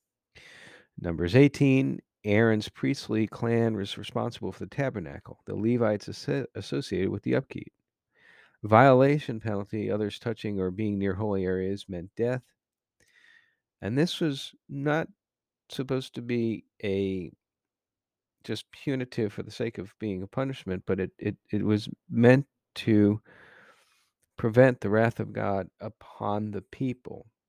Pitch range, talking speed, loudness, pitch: 100-130 Hz, 130 wpm, -28 LUFS, 110 Hz